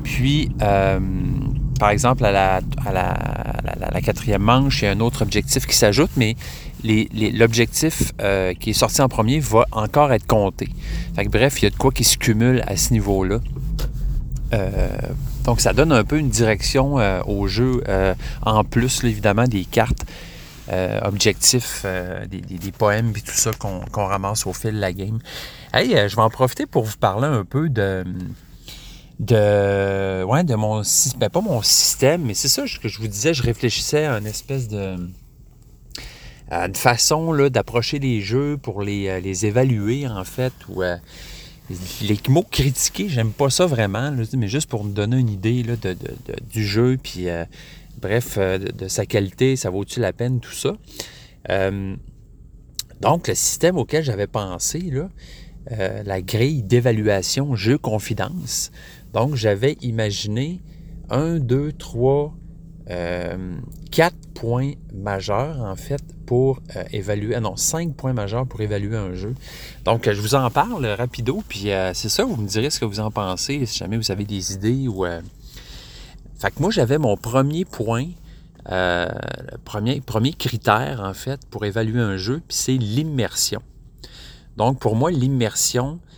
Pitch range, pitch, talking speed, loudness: 100-135 Hz, 115 Hz, 180 wpm, -20 LUFS